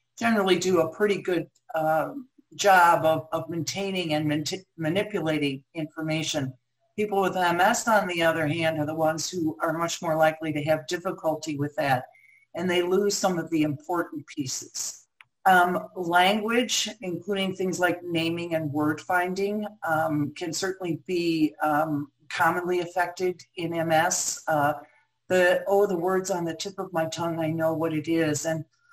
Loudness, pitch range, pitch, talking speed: -26 LUFS, 155-185 Hz, 165 Hz, 160 wpm